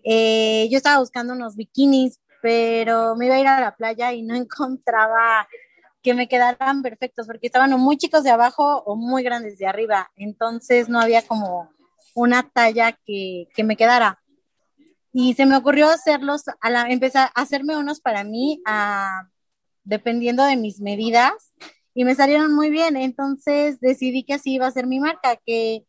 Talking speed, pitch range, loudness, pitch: 170 wpm, 225-275 Hz, -19 LUFS, 245 Hz